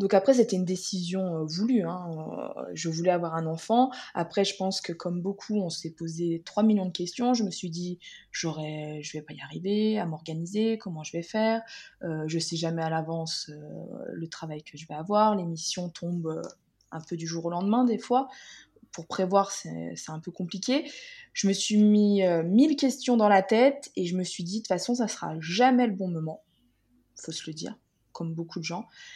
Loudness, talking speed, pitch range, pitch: -28 LUFS, 220 wpm, 165-215 Hz, 180 Hz